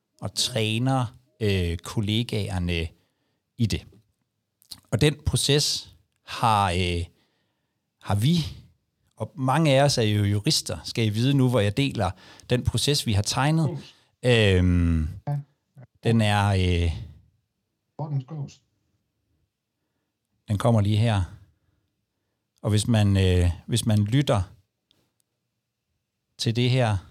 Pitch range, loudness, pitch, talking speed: 100-125 Hz, -24 LUFS, 110 Hz, 110 wpm